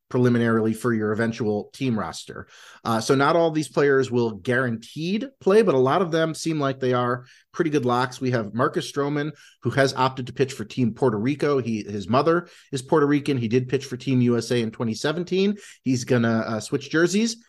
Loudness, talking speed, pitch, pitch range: -23 LUFS, 200 wpm, 130 Hz, 120-155 Hz